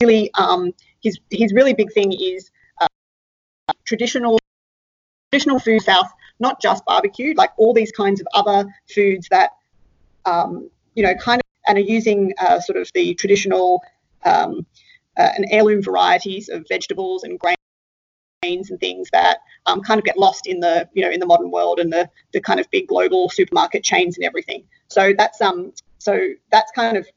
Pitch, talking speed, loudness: 220 Hz, 175 wpm, -18 LUFS